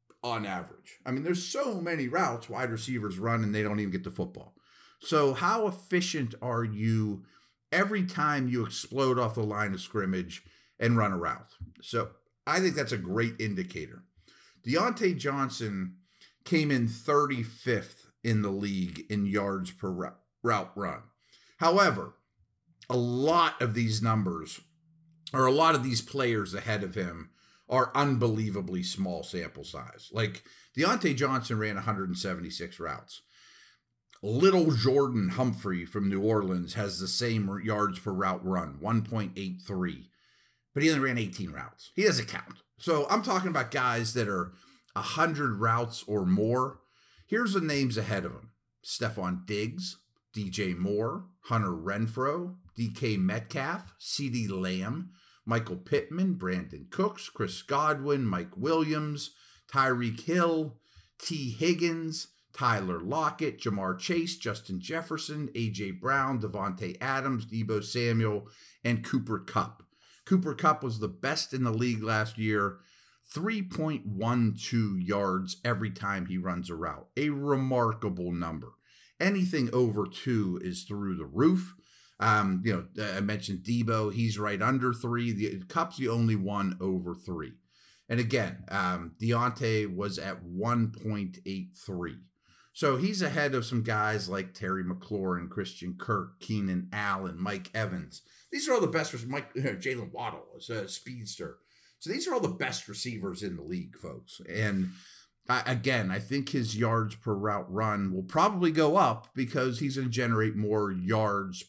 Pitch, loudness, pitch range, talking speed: 115 Hz, -30 LUFS, 100-140 Hz, 150 wpm